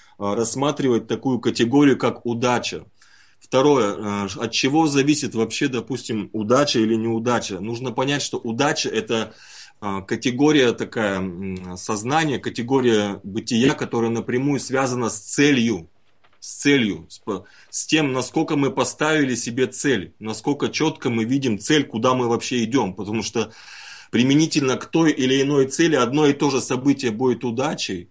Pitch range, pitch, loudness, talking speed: 115-140 Hz, 125 Hz, -21 LUFS, 130 wpm